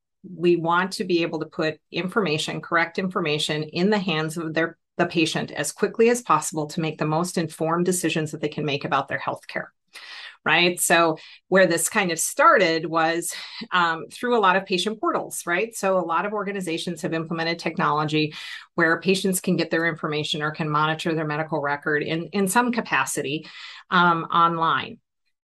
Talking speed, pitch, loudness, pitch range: 180 wpm, 165 Hz, -23 LUFS, 160-185 Hz